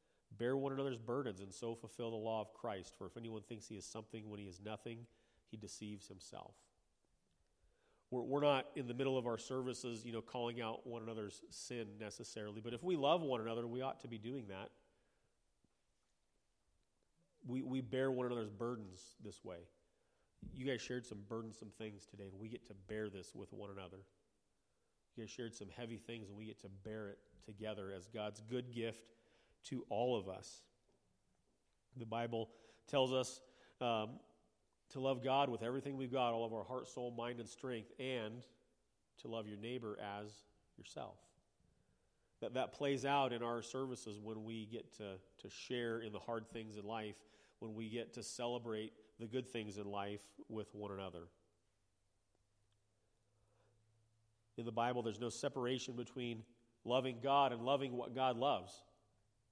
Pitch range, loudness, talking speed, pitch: 105-125 Hz, -44 LUFS, 175 wpm, 115 Hz